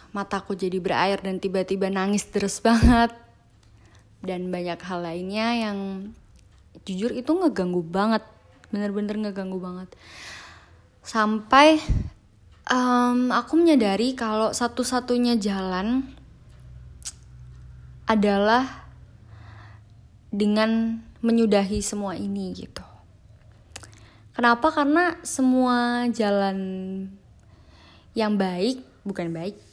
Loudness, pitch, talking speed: -23 LUFS, 200 Hz, 85 wpm